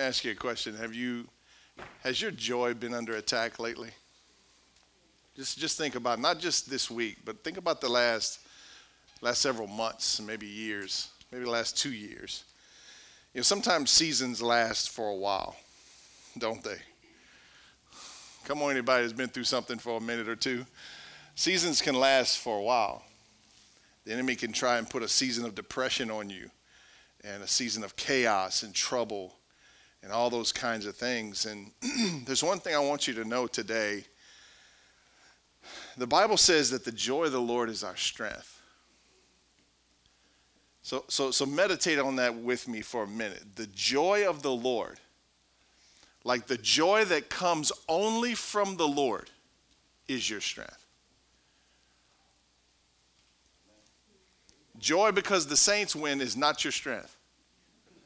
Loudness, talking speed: -29 LUFS, 155 wpm